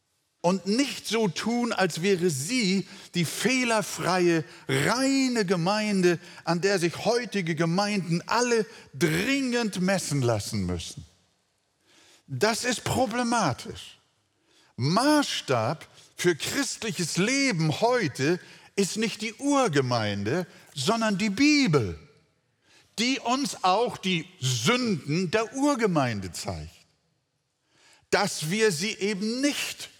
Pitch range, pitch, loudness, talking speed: 165-230 Hz, 195 Hz, -26 LUFS, 100 wpm